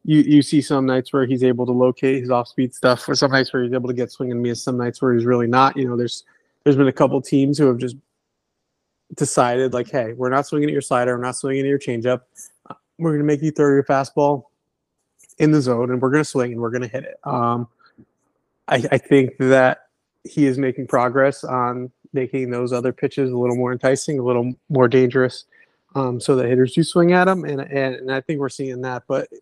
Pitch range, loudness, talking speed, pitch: 125-140 Hz, -19 LUFS, 240 wpm, 130 Hz